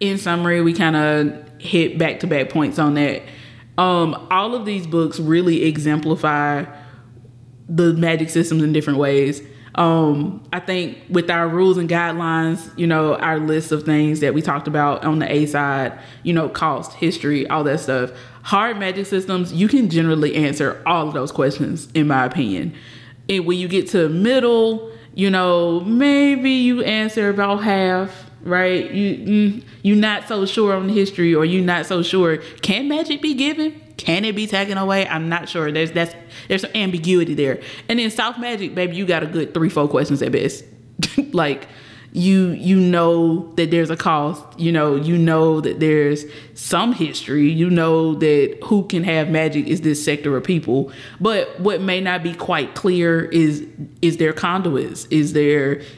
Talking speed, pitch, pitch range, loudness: 180 wpm, 165 Hz, 150-185 Hz, -18 LUFS